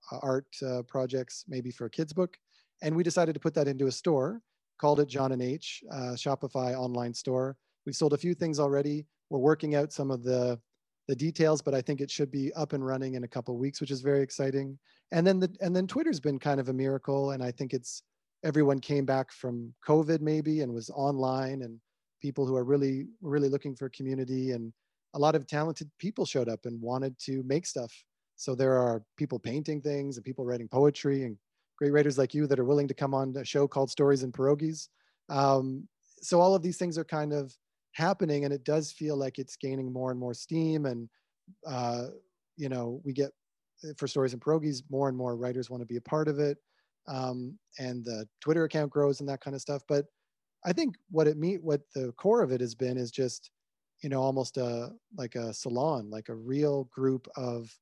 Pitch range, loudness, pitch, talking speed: 130-150 Hz, -31 LUFS, 140 Hz, 220 wpm